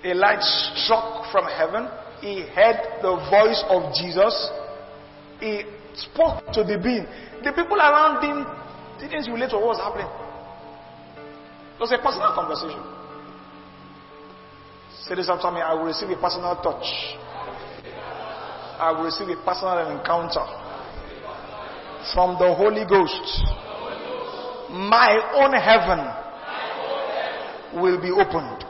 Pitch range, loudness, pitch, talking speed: 175-230 Hz, -22 LUFS, 205 Hz, 120 wpm